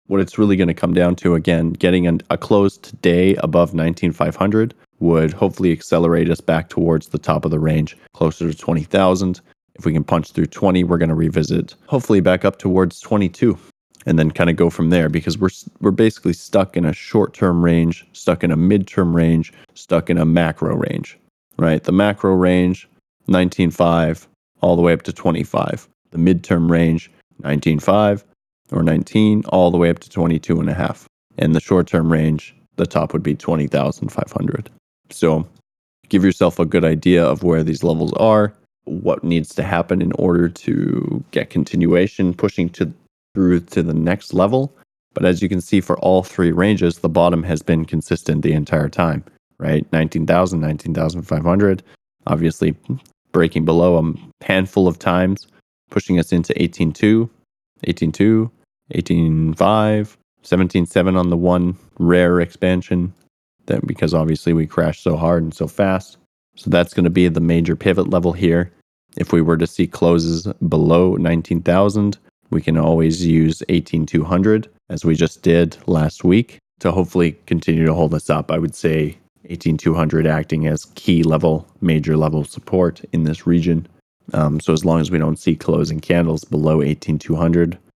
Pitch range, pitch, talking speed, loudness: 80-90 Hz, 85 Hz, 170 wpm, -17 LUFS